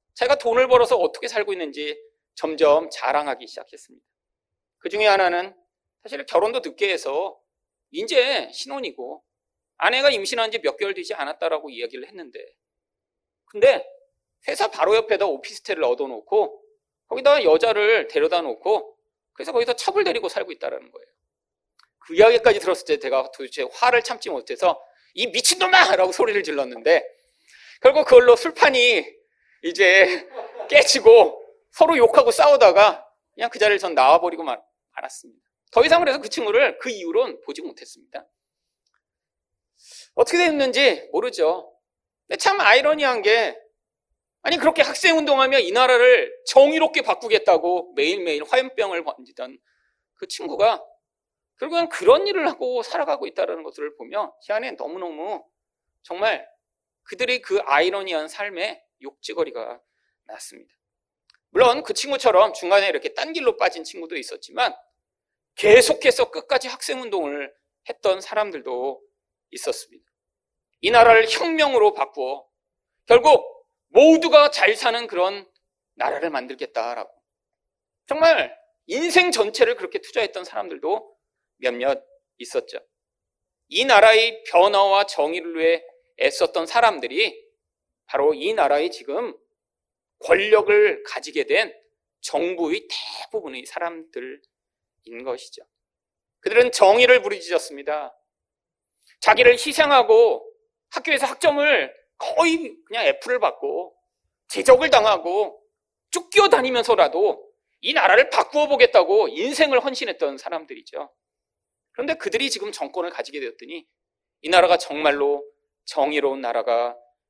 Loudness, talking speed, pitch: -19 LUFS, 295 characters per minute, 380 Hz